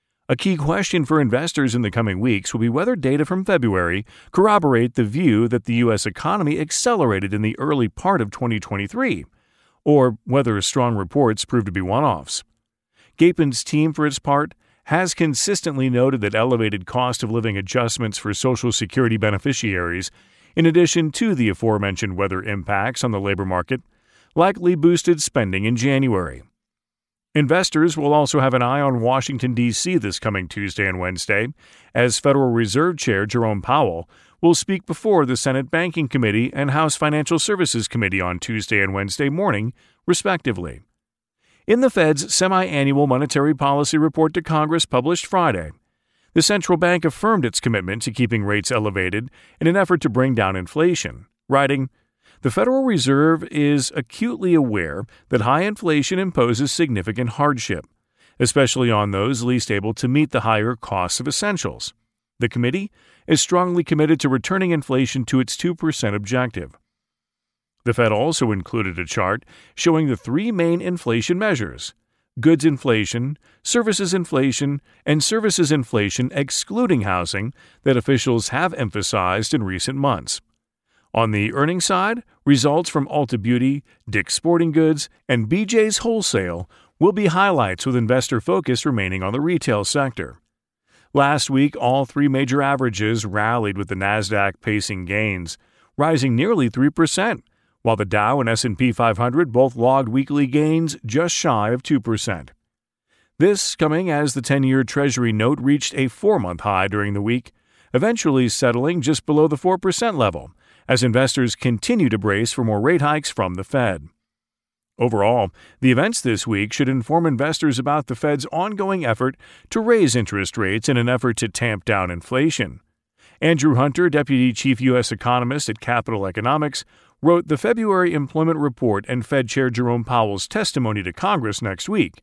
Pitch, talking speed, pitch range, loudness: 130 Hz, 155 wpm, 110-155 Hz, -19 LUFS